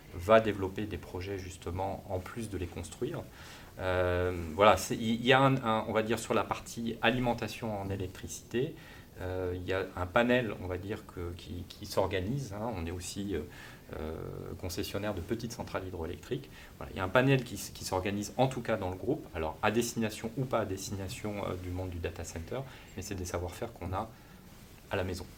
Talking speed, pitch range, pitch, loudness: 205 wpm, 90-115 Hz, 100 Hz, -33 LUFS